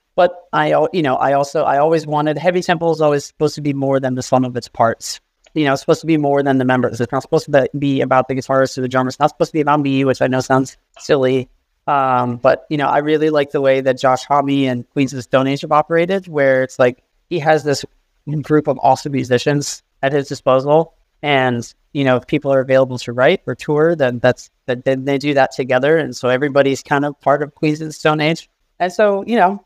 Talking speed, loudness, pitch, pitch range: 250 wpm, -16 LUFS, 140 Hz, 130-150 Hz